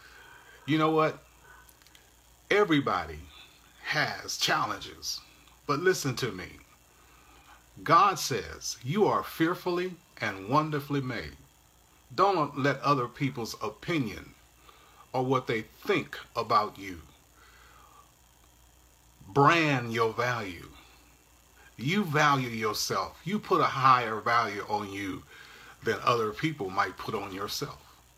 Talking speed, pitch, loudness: 105 wpm, 115 Hz, -28 LUFS